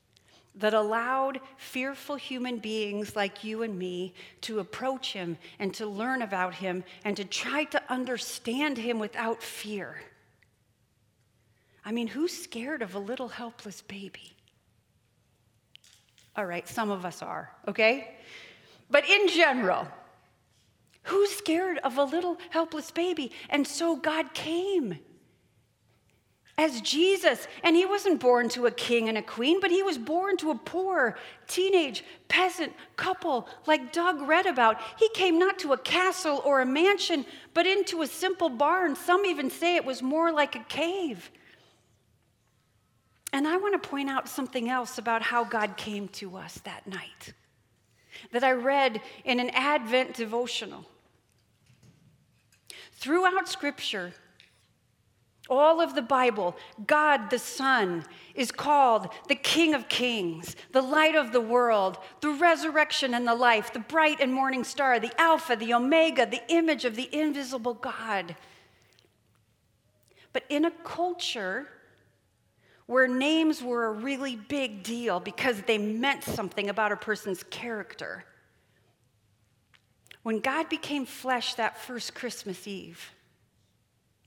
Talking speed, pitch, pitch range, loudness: 140 wpm, 245 Hz, 185-300 Hz, -27 LUFS